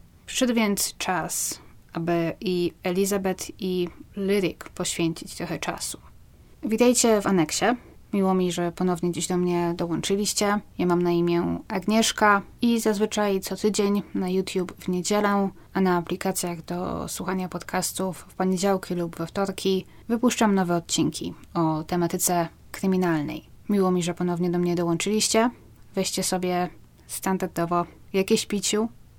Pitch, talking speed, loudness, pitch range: 185 Hz, 130 wpm, -25 LUFS, 175-200 Hz